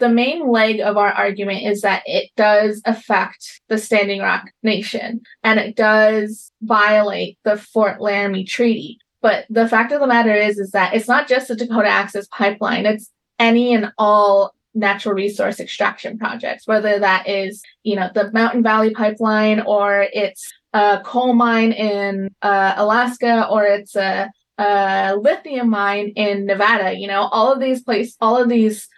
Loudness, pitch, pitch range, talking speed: -17 LUFS, 215 Hz, 200-230 Hz, 170 wpm